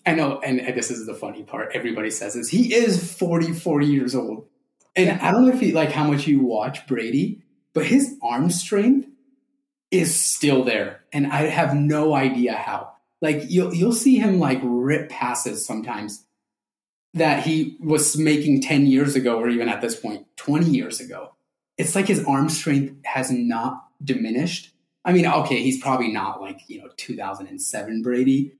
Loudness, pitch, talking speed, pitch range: -21 LUFS, 150 Hz, 175 wpm, 125-180 Hz